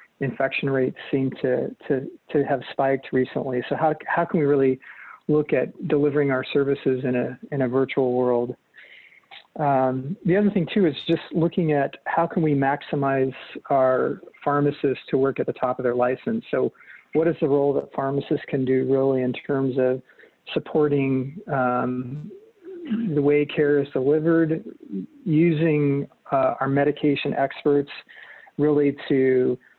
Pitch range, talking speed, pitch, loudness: 130-155 Hz, 155 wpm, 140 Hz, -23 LUFS